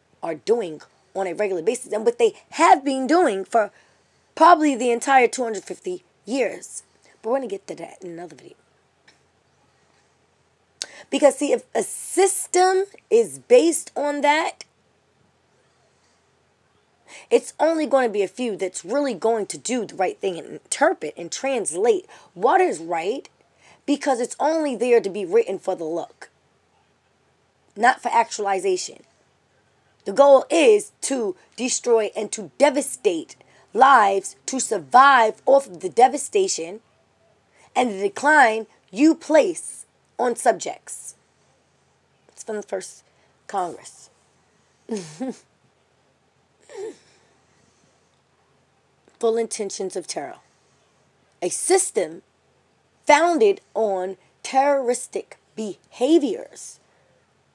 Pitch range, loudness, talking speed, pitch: 220-345 Hz, -21 LUFS, 110 wpm, 265 Hz